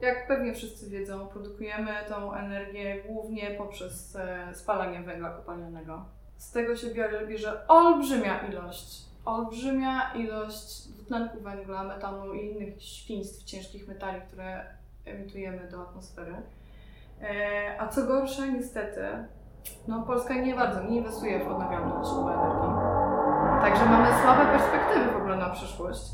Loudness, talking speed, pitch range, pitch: -28 LUFS, 130 wpm, 195-230 Hz, 205 Hz